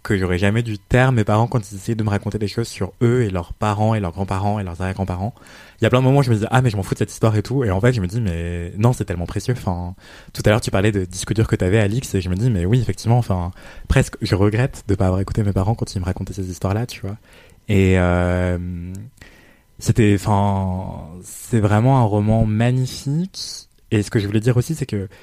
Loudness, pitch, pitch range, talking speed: -20 LUFS, 105 Hz, 95-120 Hz, 265 wpm